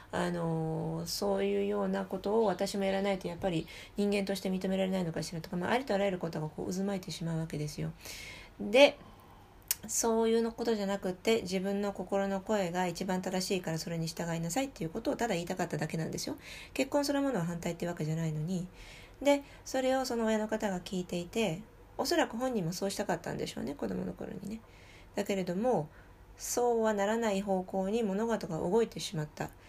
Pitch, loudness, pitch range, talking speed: 195 Hz, -33 LUFS, 170-220 Hz, 430 characters per minute